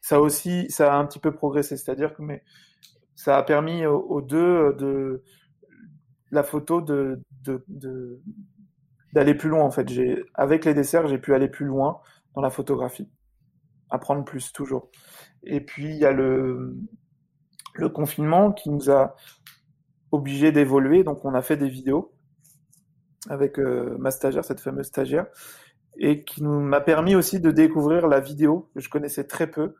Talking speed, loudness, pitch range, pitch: 165 wpm, -23 LUFS, 135-155 Hz, 145 Hz